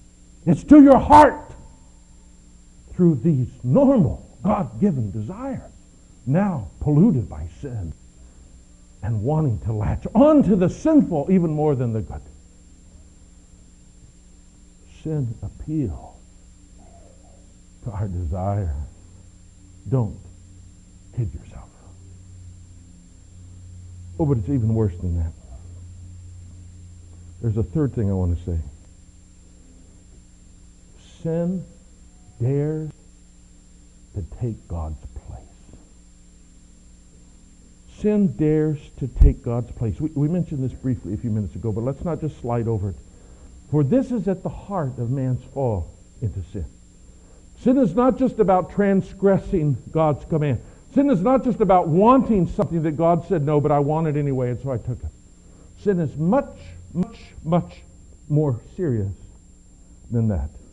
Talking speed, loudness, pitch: 125 wpm, -21 LUFS, 100 Hz